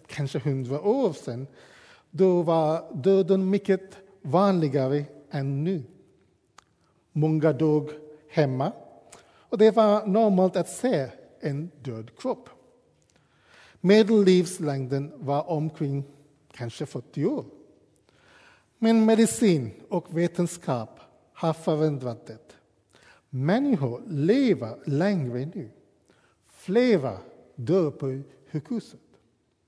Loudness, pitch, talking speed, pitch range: -25 LUFS, 155 Hz, 85 wpm, 140-190 Hz